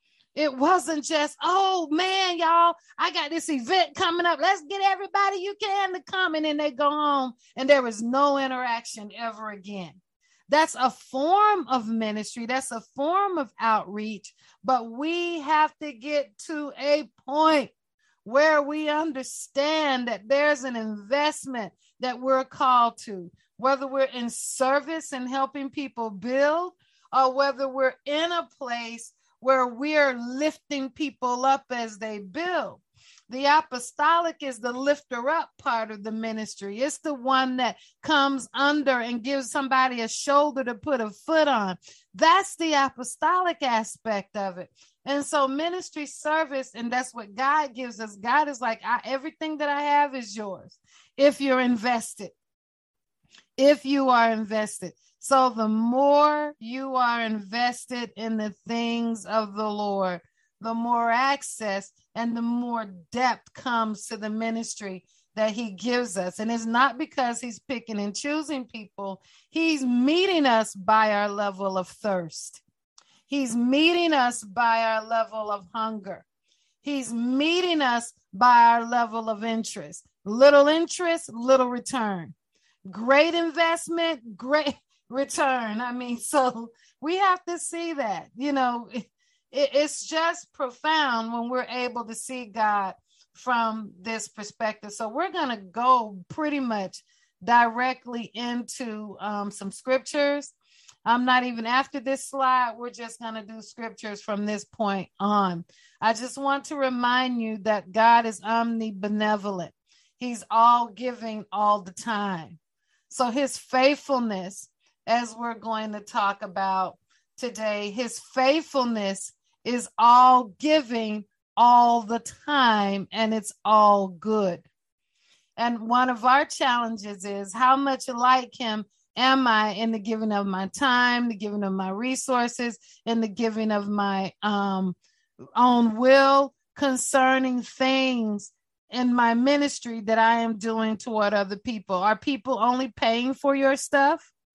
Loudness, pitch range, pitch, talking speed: -24 LUFS, 220-285 Hz, 245 Hz, 145 wpm